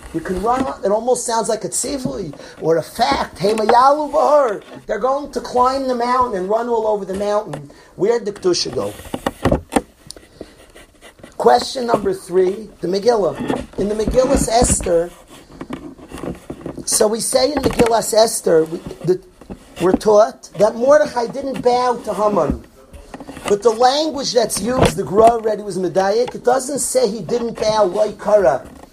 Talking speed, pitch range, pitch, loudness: 150 wpm, 205-255 Hz, 230 Hz, -17 LUFS